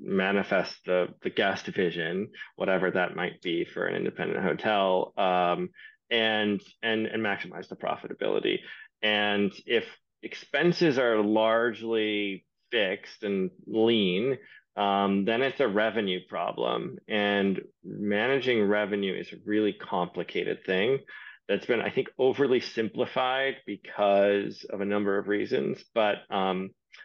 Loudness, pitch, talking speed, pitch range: -28 LUFS, 105 Hz, 125 wpm, 100-115 Hz